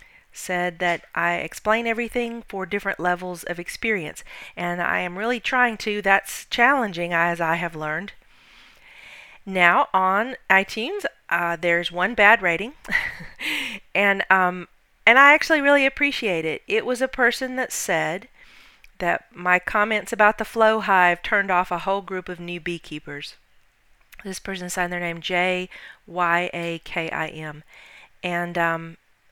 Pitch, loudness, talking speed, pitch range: 190 Hz, -21 LUFS, 145 wpm, 175-225 Hz